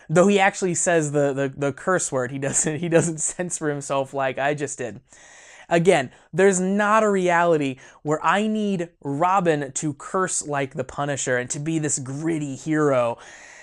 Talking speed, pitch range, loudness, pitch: 170 wpm, 140-180 Hz, -22 LUFS, 155 Hz